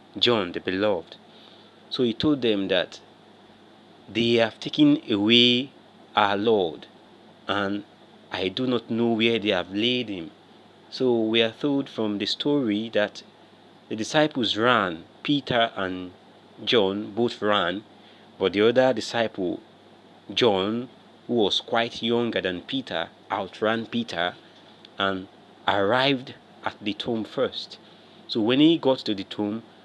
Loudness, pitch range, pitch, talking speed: -24 LUFS, 105-125 Hz, 115 Hz, 135 wpm